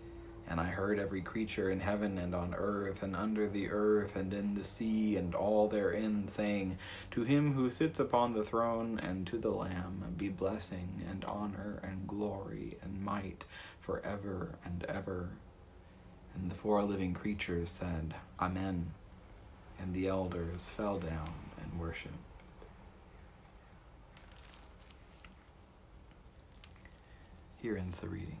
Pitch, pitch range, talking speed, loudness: 95 Hz, 90-105 Hz, 130 wpm, -37 LUFS